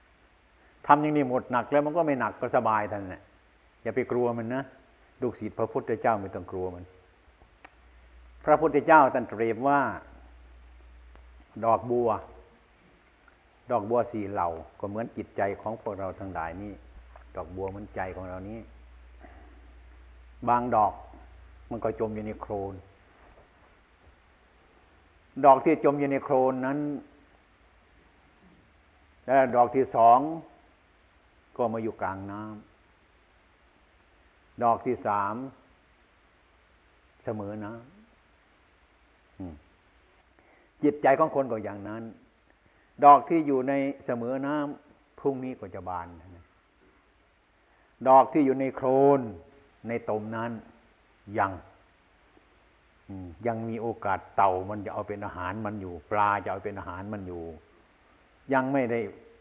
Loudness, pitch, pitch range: -27 LUFS, 100 Hz, 80-120 Hz